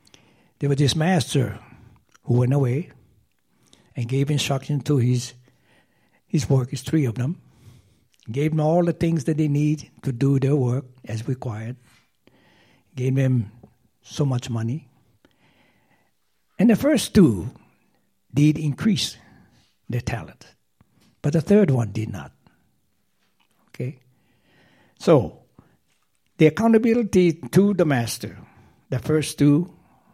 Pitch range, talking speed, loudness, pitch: 120-155 Hz, 120 wpm, -22 LUFS, 135 Hz